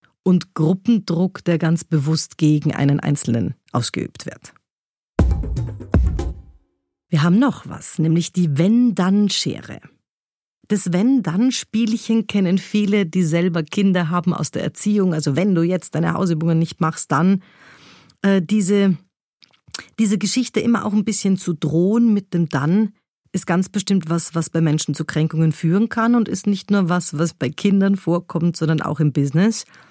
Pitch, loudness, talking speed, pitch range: 175 Hz, -19 LUFS, 145 wpm, 160-200 Hz